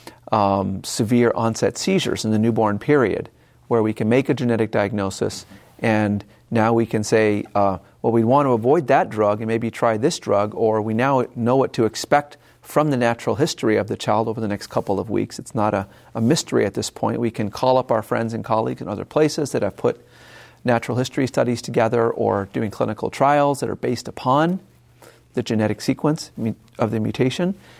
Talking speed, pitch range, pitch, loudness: 200 wpm, 110-130 Hz, 115 Hz, -21 LUFS